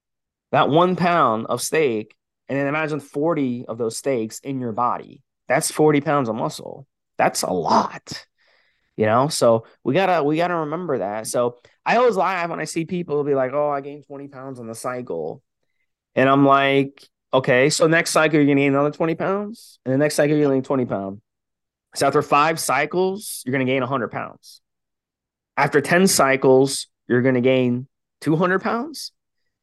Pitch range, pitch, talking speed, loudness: 130-155 Hz, 140 Hz, 180 wpm, -20 LUFS